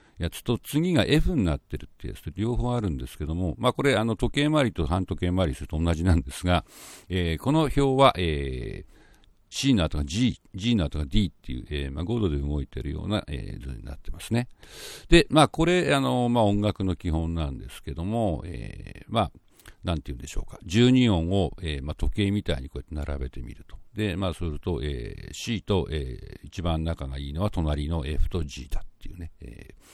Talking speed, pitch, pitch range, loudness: 350 characters per minute, 90 Hz, 75-110 Hz, -26 LUFS